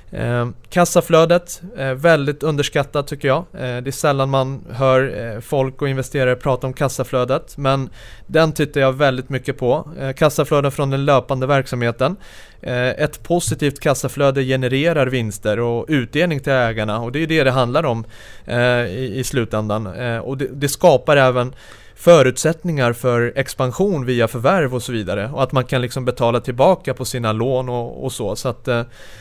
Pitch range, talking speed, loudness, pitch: 125-145 Hz, 175 wpm, -18 LUFS, 130 Hz